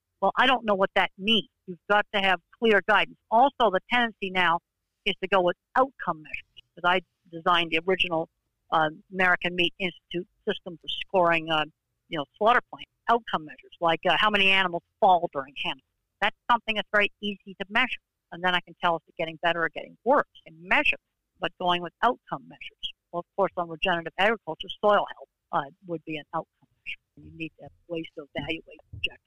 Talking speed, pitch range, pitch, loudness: 205 wpm, 165-200 Hz, 180 Hz, -26 LUFS